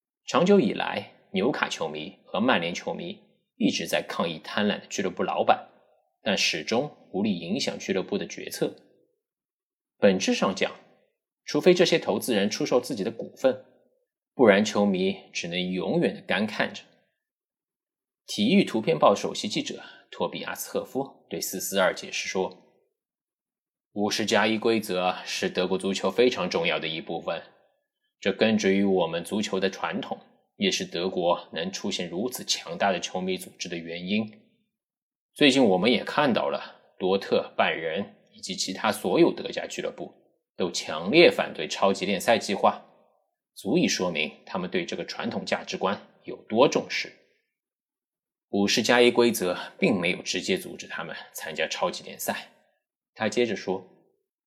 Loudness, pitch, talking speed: -26 LUFS, 175 Hz, 240 characters per minute